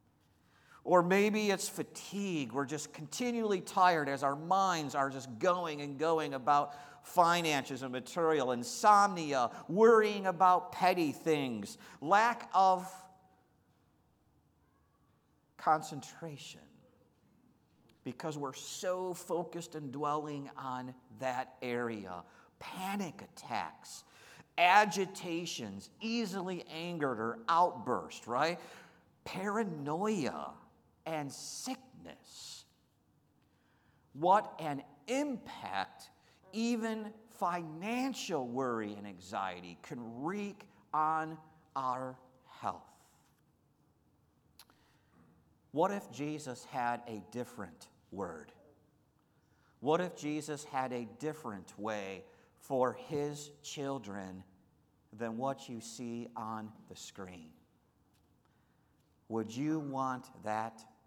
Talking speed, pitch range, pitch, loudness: 85 wpm, 125-180 Hz, 150 Hz, -34 LUFS